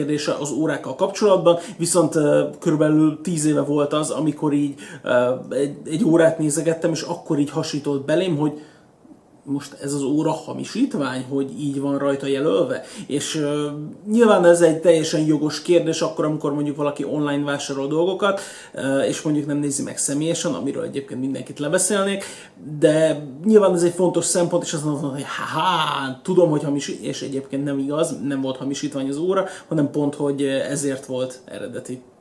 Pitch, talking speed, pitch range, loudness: 150 Hz, 160 wpm, 140-165 Hz, -21 LUFS